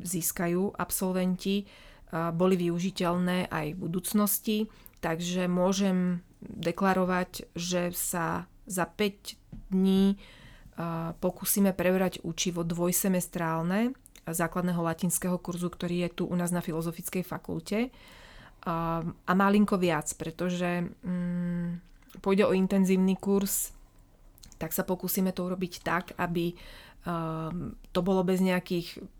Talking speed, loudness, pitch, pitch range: 100 wpm, -29 LUFS, 180 Hz, 170-190 Hz